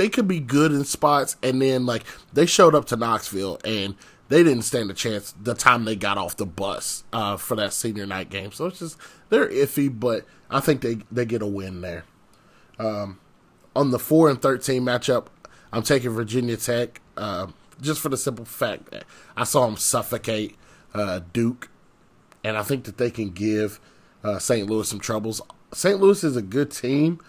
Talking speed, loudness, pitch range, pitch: 195 wpm, -23 LUFS, 105-140 Hz, 120 Hz